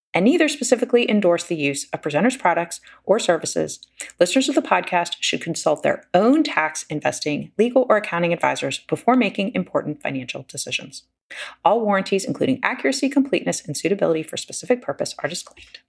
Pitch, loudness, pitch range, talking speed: 195 Hz, -21 LUFS, 165-250 Hz, 160 wpm